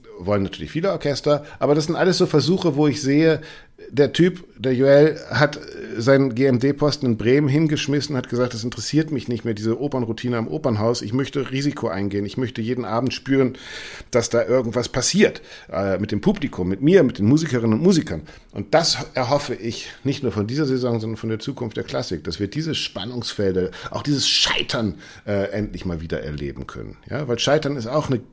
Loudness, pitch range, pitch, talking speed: -21 LUFS, 110-145 Hz, 125 Hz, 195 wpm